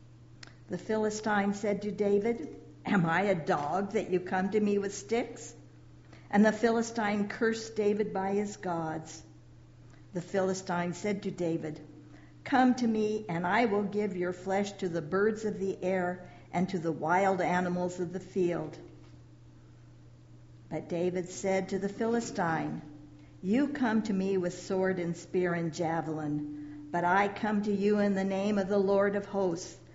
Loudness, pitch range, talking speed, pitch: -31 LUFS, 165-205 Hz, 160 wpm, 190 Hz